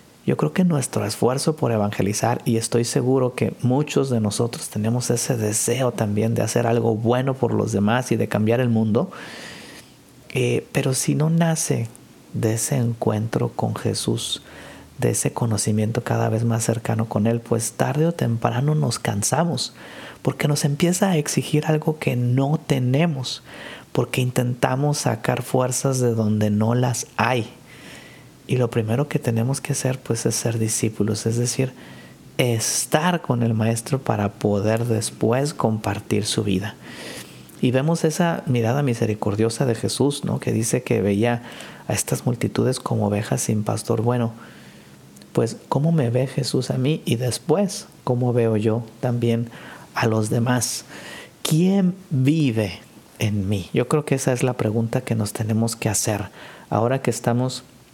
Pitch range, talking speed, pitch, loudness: 110-135 Hz, 155 wpm, 120 Hz, -22 LUFS